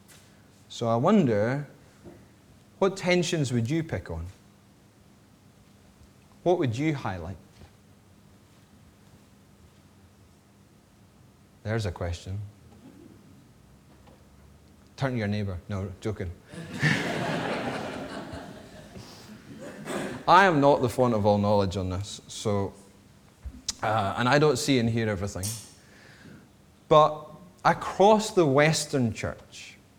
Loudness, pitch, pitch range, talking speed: -26 LUFS, 105 Hz, 100-125 Hz, 90 wpm